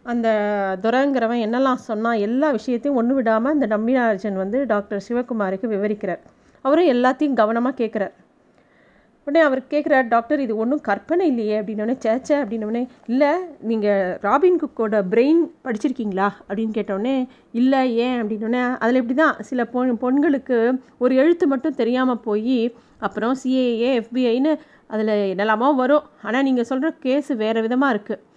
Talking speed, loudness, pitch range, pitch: 135 wpm, -20 LUFS, 220-270 Hz, 245 Hz